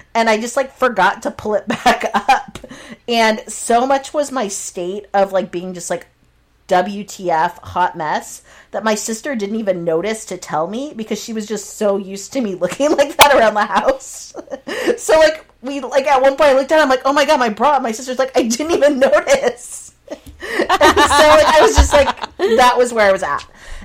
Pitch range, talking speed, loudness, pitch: 200-275 Hz, 215 wpm, -15 LUFS, 235 Hz